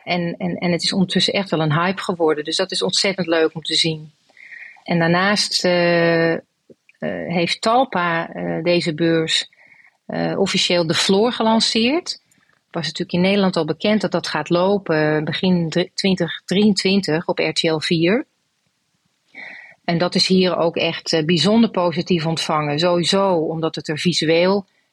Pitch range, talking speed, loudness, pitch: 165-190 Hz, 150 wpm, -18 LUFS, 175 Hz